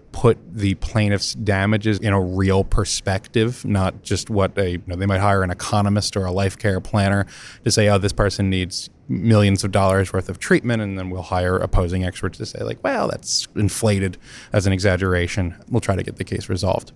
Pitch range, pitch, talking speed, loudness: 95-105 Hz, 100 Hz, 205 wpm, -20 LUFS